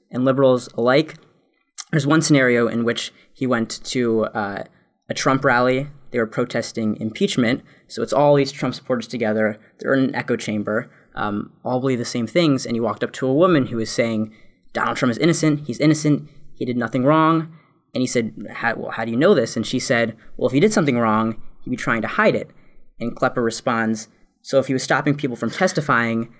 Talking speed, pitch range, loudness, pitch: 210 wpm, 115-140 Hz, -20 LUFS, 125 Hz